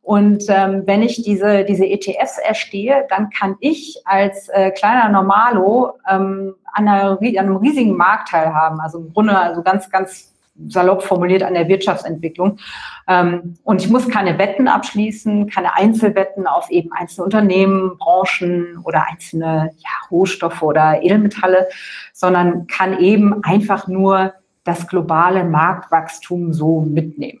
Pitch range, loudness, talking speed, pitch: 175-205 Hz, -15 LUFS, 140 wpm, 190 Hz